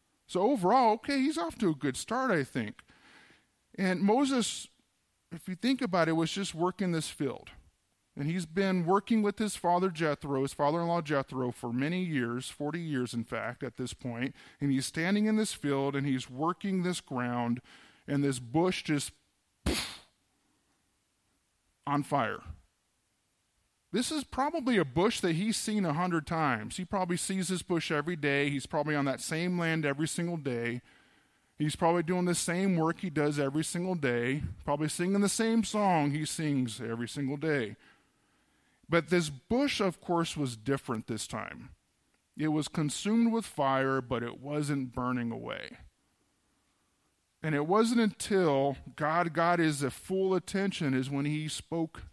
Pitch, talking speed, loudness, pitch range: 160 Hz, 165 wpm, -31 LUFS, 135-185 Hz